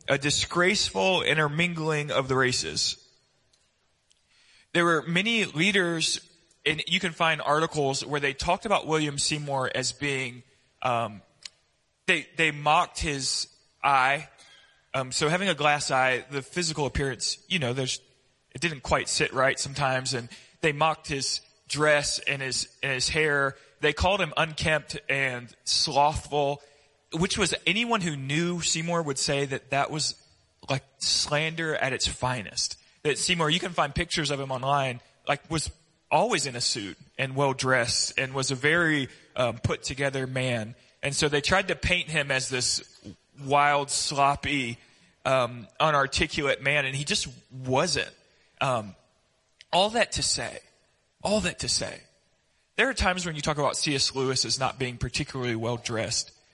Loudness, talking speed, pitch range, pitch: -26 LUFS, 155 wpm, 130-160 Hz, 145 Hz